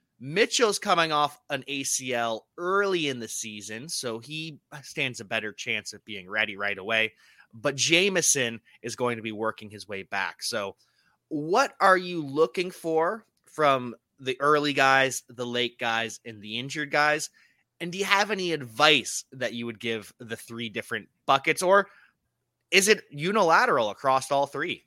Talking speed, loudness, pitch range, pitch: 165 wpm, -25 LUFS, 115-160 Hz, 135 Hz